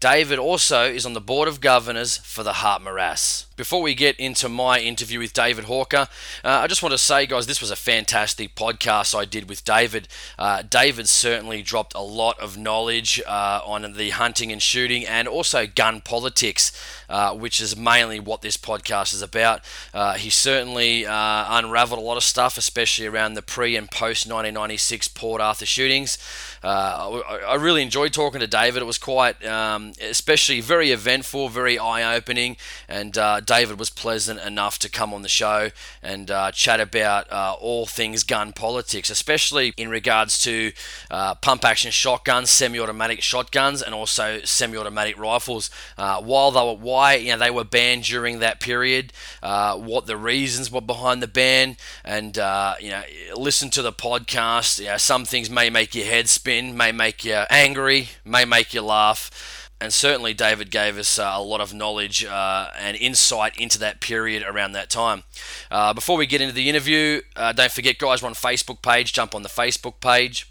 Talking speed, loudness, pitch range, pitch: 185 wpm, -20 LUFS, 110-125 Hz, 115 Hz